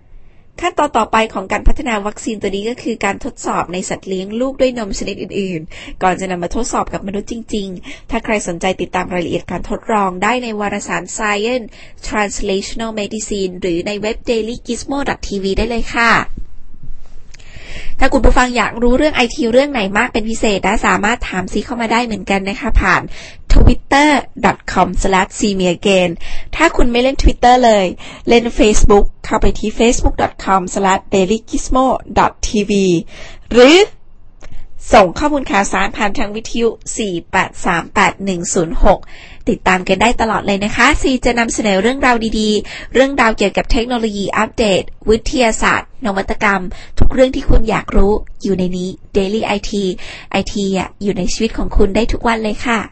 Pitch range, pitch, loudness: 195-240 Hz, 215 Hz, -15 LUFS